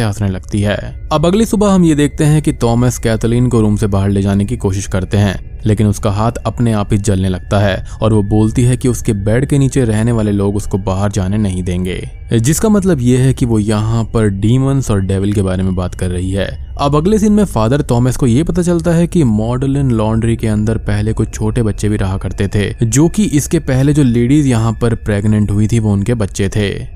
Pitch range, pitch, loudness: 100-130 Hz, 110 Hz, -14 LUFS